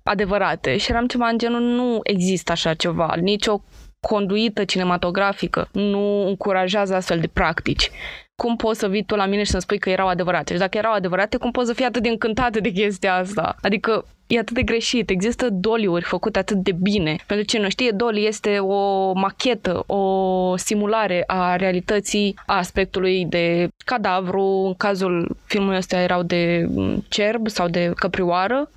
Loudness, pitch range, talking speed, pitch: -21 LUFS, 185-220 Hz, 170 wpm, 200 Hz